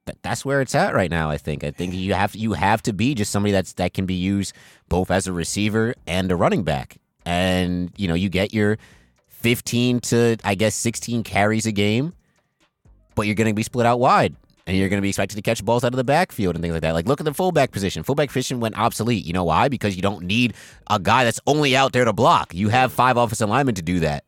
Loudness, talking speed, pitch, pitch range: -21 LUFS, 255 wpm, 105 Hz, 95-120 Hz